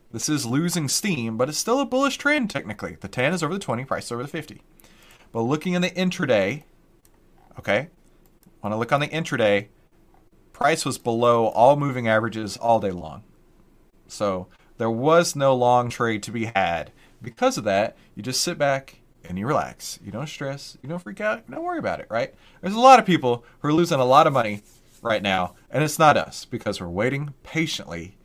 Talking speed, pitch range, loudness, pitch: 205 wpm, 110-165 Hz, -22 LUFS, 130 Hz